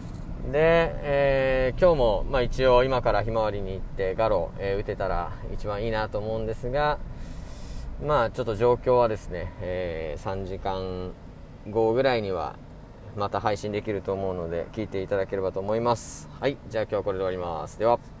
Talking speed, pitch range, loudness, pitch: 355 characters per minute, 95-120 Hz, -26 LUFS, 105 Hz